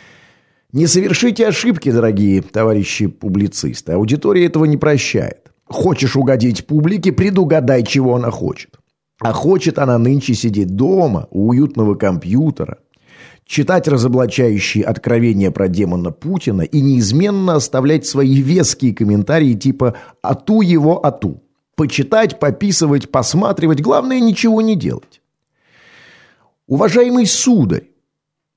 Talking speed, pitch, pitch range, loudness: 105 wpm, 140 Hz, 115-175 Hz, -14 LUFS